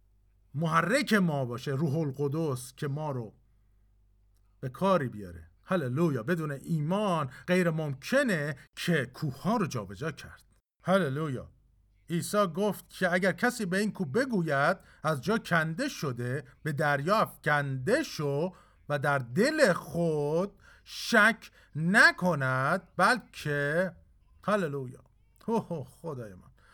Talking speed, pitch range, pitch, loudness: 115 wpm, 130-185 Hz, 155 Hz, -29 LUFS